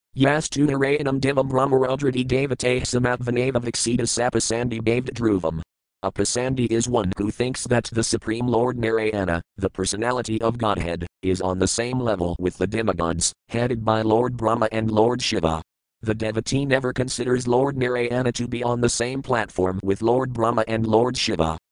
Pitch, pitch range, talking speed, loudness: 115 Hz, 105-125 Hz, 160 wpm, -22 LUFS